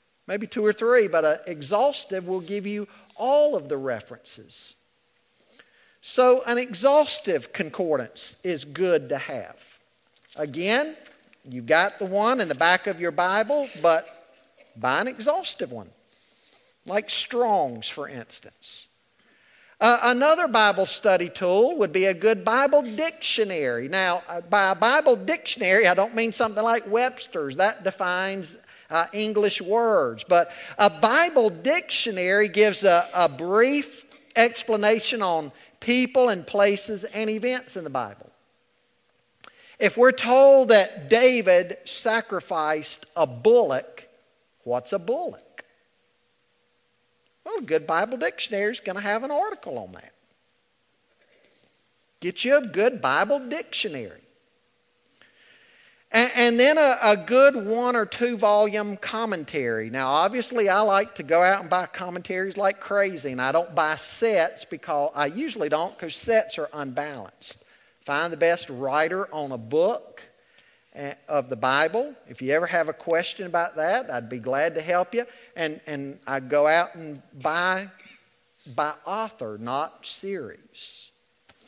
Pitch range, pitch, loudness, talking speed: 170-245 Hz, 205 Hz, -23 LUFS, 140 wpm